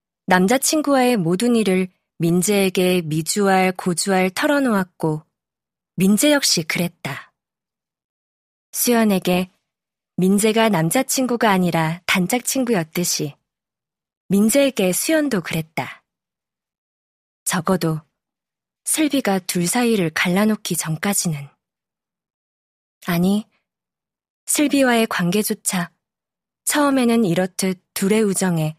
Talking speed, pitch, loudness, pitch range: 215 characters per minute, 185 Hz, -19 LUFS, 170-225 Hz